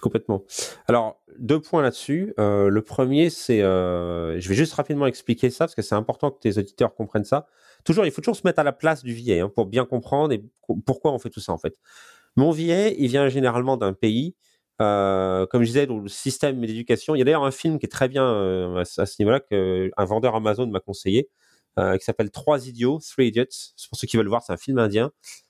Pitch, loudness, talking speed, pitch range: 120 Hz, -23 LUFS, 235 wpm, 105-140 Hz